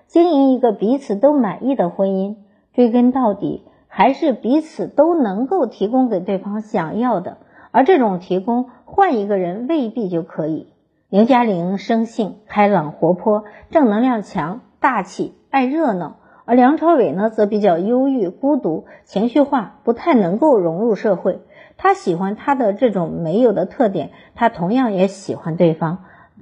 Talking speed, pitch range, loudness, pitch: 240 characters per minute, 195-260 Hz, -17 LUFS, 220 Hz